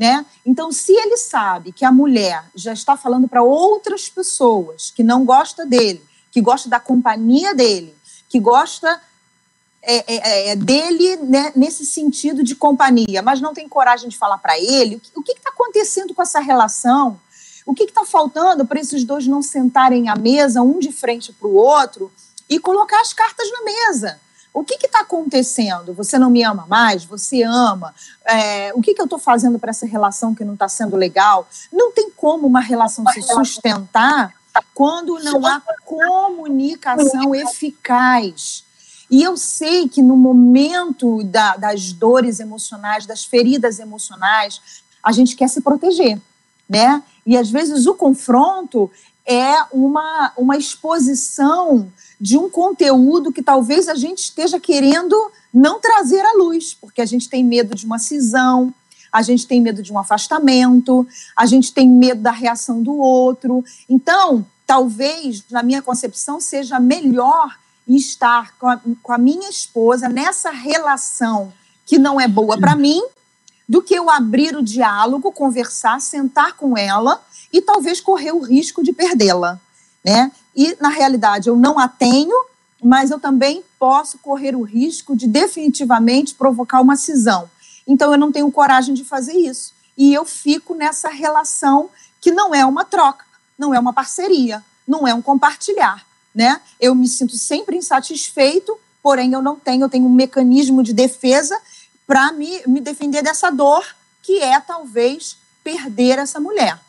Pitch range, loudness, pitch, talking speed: 240-305 Hz, -15 LUFS, 265 Hz, 160 wpm